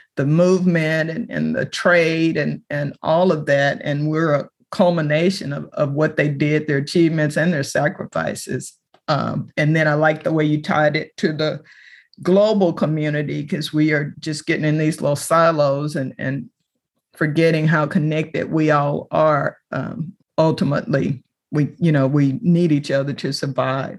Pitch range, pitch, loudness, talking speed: 145-165 Hz, 155 Hz, -19 LUFS, 170 wpm